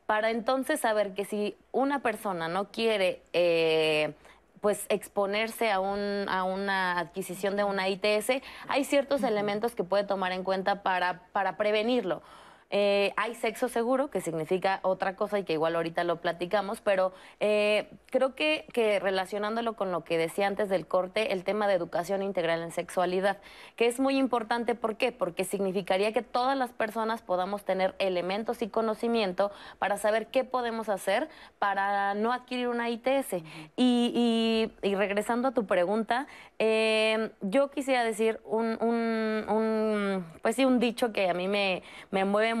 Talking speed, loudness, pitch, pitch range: 165 wpm, -29 LUFS, 205 Hz, 190-230 Hz